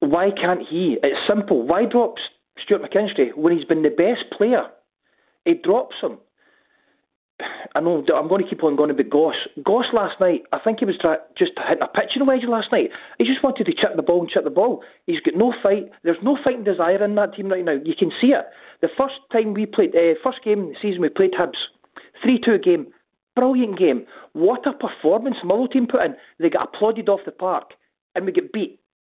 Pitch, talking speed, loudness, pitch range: 210 Hz, 215 wpm, -20 LUFS, 185-260 Hz